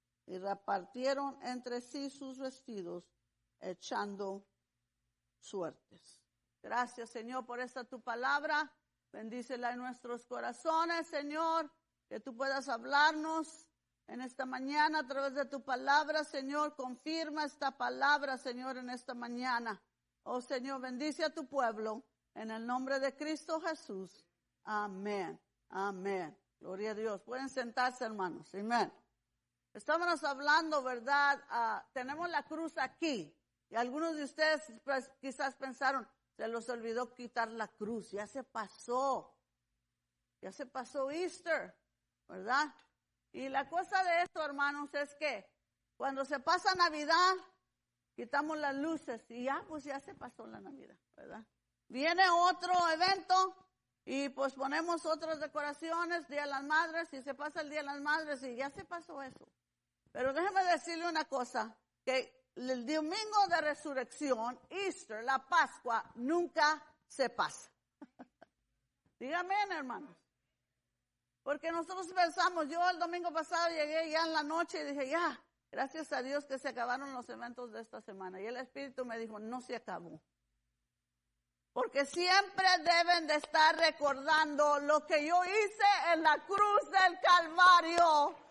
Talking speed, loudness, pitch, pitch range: 140 wpm, -35 LUFS, 280 Hz, 245-320 Hz